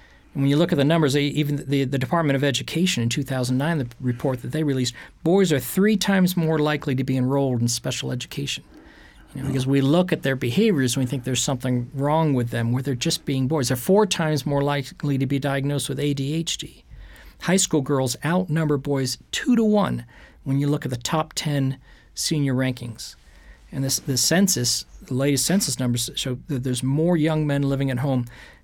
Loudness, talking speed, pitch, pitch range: -22 LUFS, 200 wpm, 140 Hz, 130-155 Hz